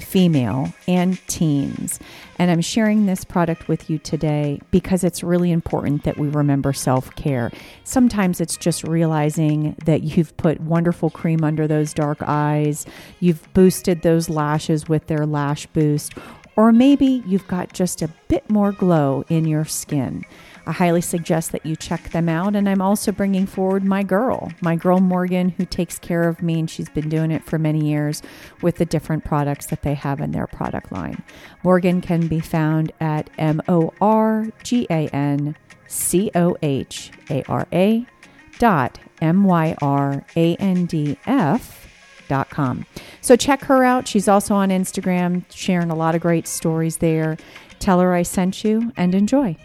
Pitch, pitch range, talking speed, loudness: 170 Hz, 155-185 Hz, 155 wpm, -19 LUFS